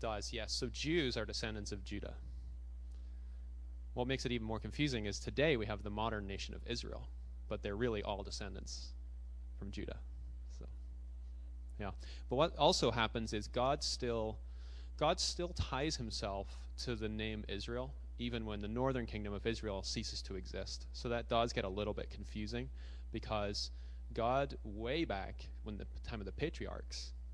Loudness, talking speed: -40 LUFS, 165 wpm